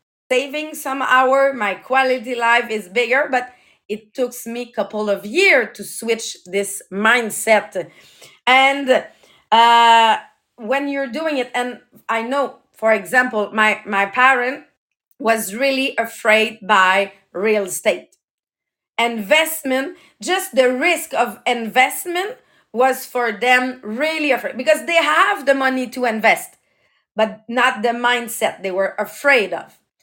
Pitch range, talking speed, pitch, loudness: 215-265 Hz, 130 wpm, 245 Hz, -17 LUFS